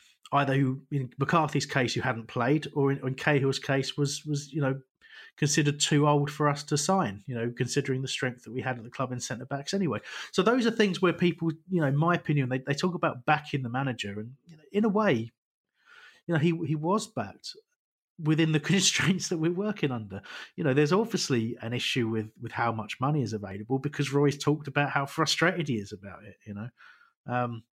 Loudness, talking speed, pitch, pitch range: -28 LUFS, 220 wpm, 145 Hz, 125-165 Hz